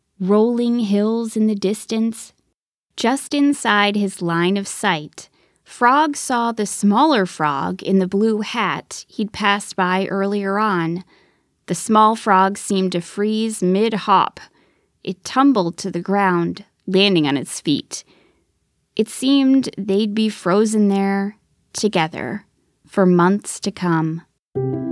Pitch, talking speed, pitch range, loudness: 200 Hz, 130 wpm, 185-220 Hz, -18 LUFS